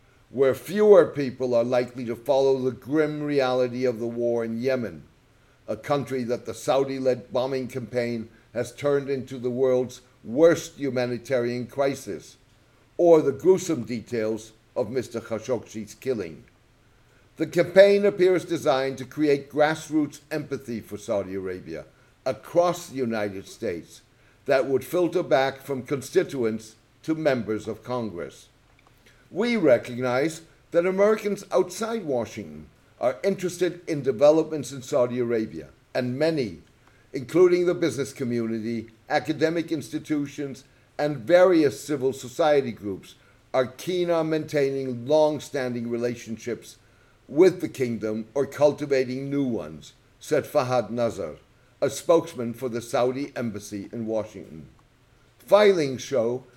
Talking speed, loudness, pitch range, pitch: 125 wpm, -25 LUFS, 120-150 Hz, 130 Hz